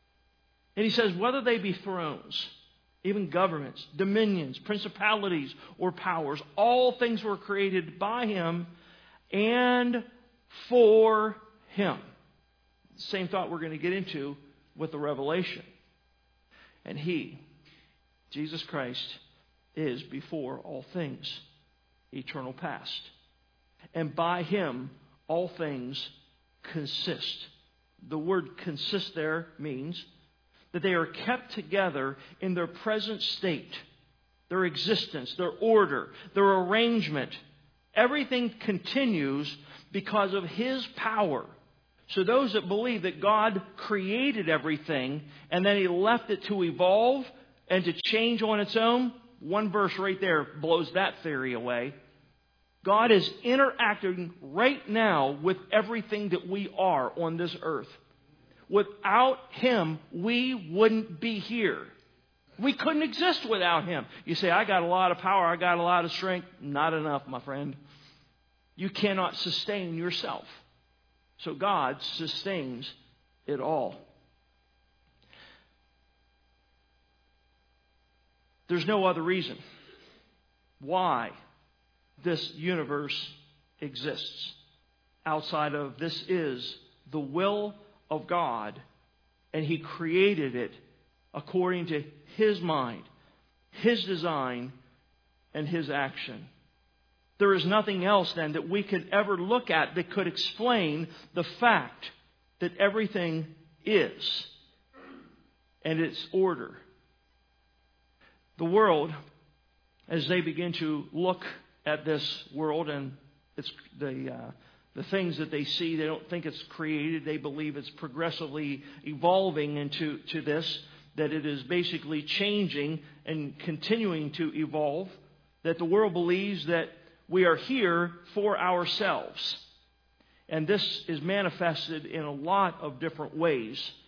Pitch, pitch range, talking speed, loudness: 170 Hz, 145-200 Hz, 120 wpm, -29 LUFS